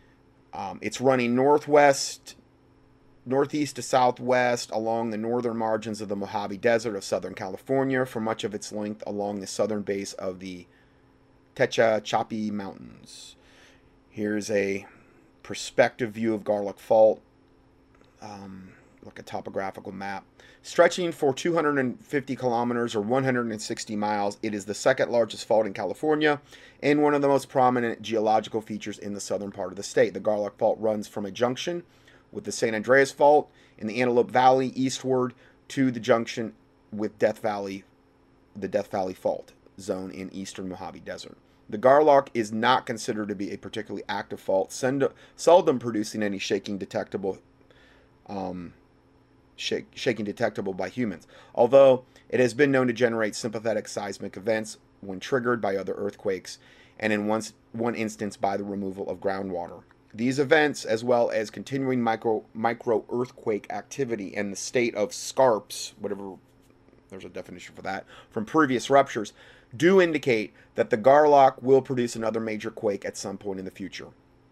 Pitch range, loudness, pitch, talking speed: 100-130 Hz, -26 LUFS, 115 Hz, 155 wpm